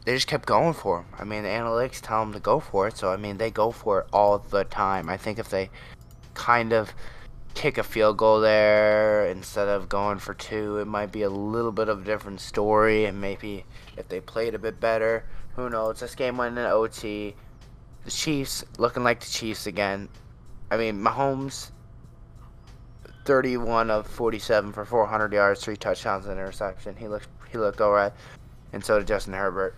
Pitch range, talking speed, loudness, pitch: 105-115 Hz, 200 wpm, -25 LUFS, 110 Hz